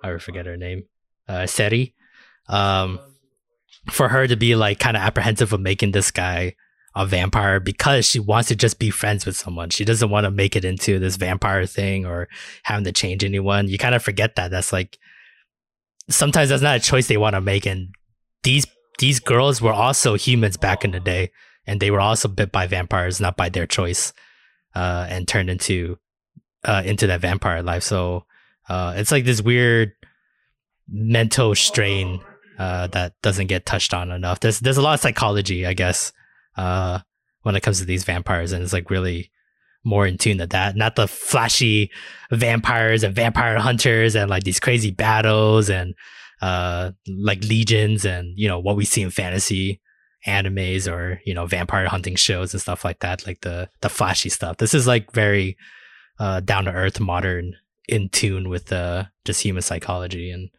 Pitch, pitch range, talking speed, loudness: 100 Hz, 90-110 Hz, 185 wpm, -20 LUFS